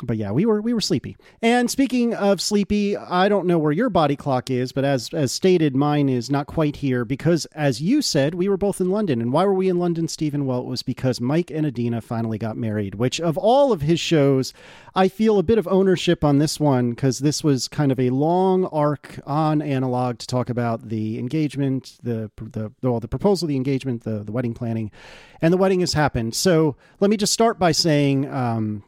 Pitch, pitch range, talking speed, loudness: 145 Hz, 125-180 Hz, 225 wpm, -21 LUFS